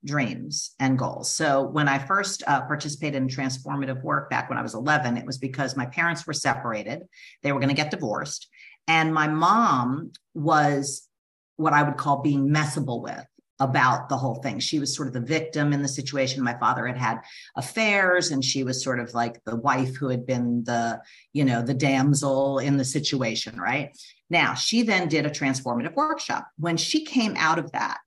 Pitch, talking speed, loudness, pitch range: 140 Hz, 195 wpm, -24 LUFS, 130-150 Hz